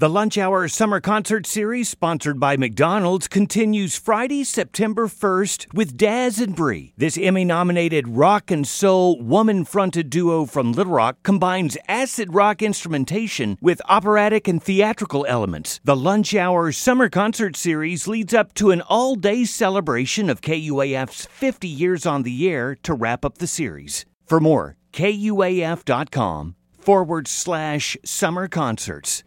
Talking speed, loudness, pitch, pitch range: 140 wpm, -20 LUFS, 180 Hz, 150-210 Hz